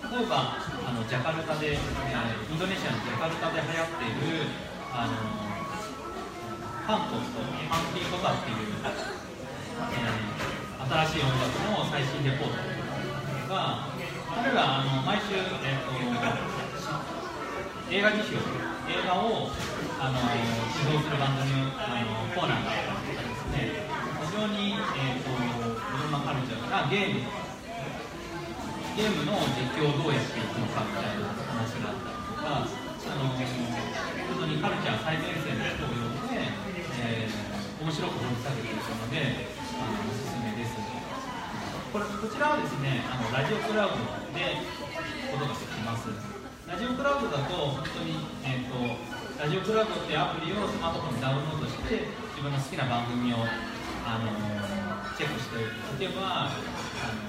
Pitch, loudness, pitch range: 135 Hz, -31 LUFS, 120-165 Hz